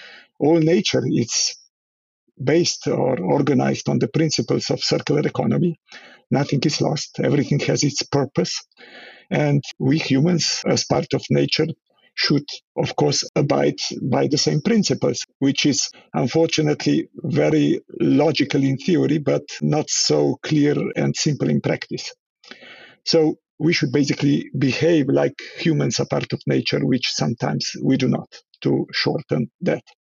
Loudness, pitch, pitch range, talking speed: -20 LUFS, 150 Hz, 135-165 Hz, 135 wpm